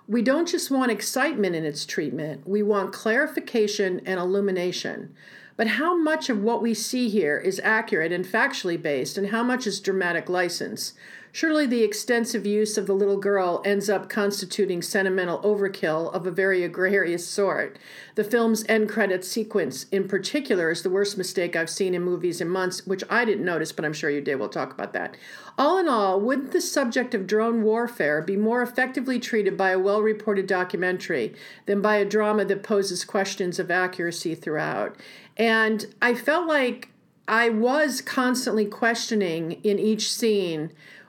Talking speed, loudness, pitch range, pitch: 170 wpm, -24 LUFS, 185-230 Hz, 205 Hz